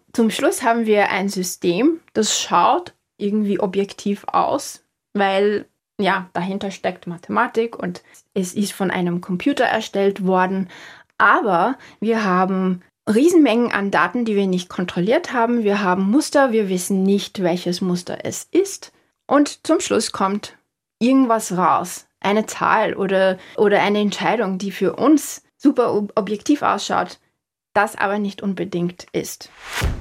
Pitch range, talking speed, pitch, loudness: 185-230 Hz, 135 wpm, 200 Hz, -19 LUFS